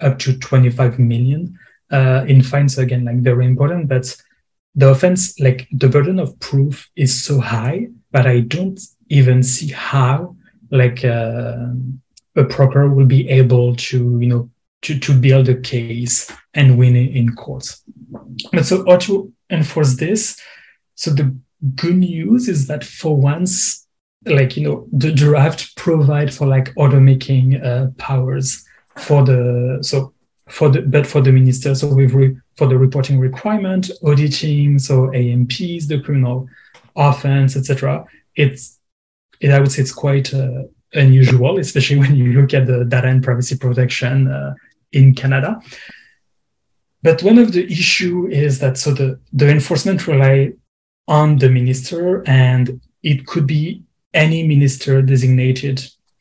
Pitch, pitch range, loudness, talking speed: 135 Hz, 130-150 Hz, -15 LUFS, 150 wpm